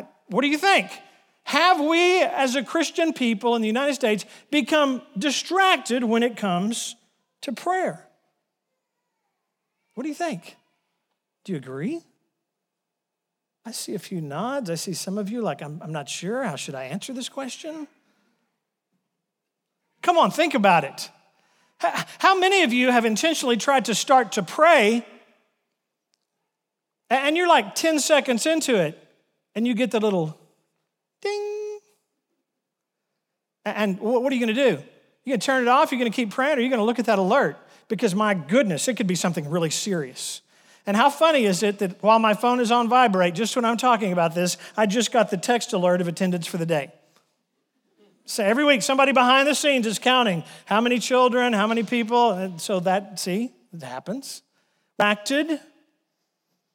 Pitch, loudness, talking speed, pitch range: 235 Hz, -22 LUFS, 175 wpm, 205-275 Hz